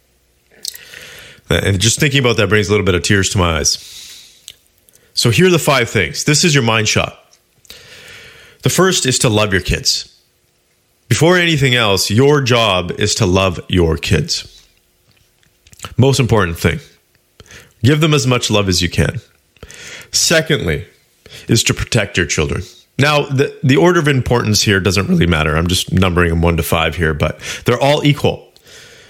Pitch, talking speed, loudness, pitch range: 110 Hz, 165 wpm, -14 LUFS, 90-135 Hz